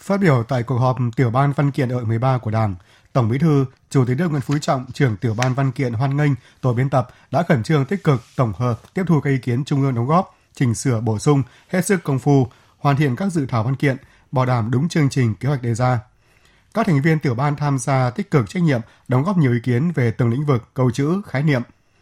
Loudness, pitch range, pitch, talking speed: -20 LUFS, 125-145 Hz, 135 Hz, 260 wpm